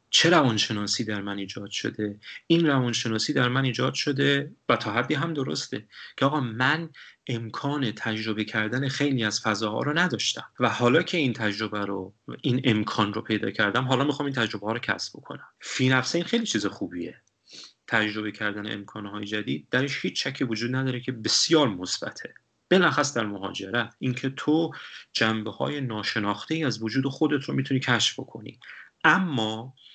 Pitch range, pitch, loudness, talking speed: 110-135 Hz, 120 Hz, -26 LUFS, 165 wpm